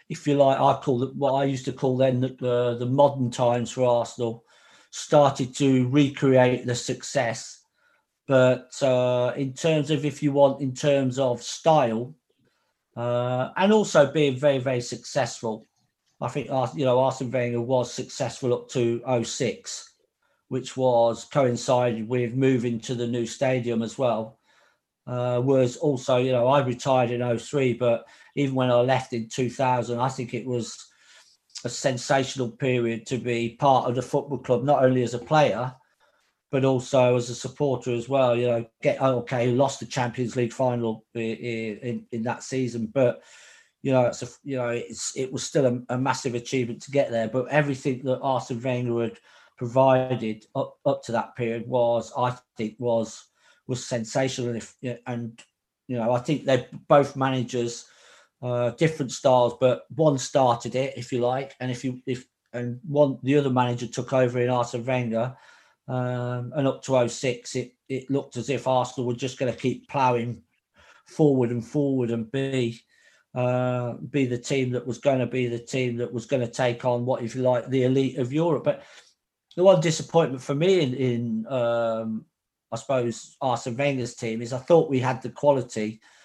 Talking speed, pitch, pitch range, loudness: 180 wpm, 125 Hz, 120-135 Hz, -25 LUFS